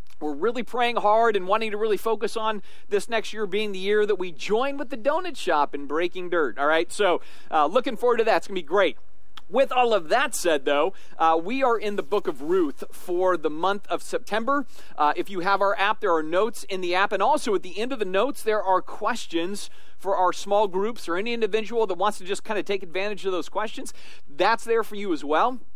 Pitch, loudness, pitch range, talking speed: 210 Hz, -25 LUFS, 185-230 Hz, 245 wpm